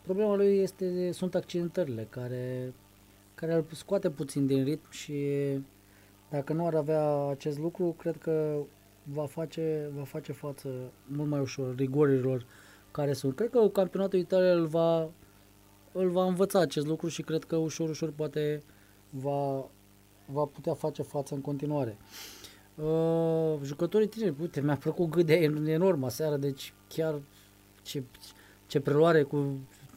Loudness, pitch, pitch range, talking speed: -31 LUFS, 150 Hz, 130-165 Hz, 140 wpm